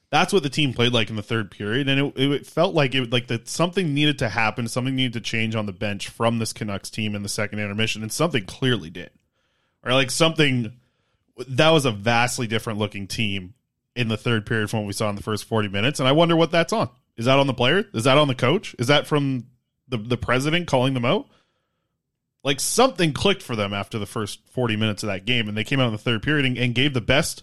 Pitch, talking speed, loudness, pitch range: 125 Hz, 250 wpm, -22 LUFS, 110-140 Hz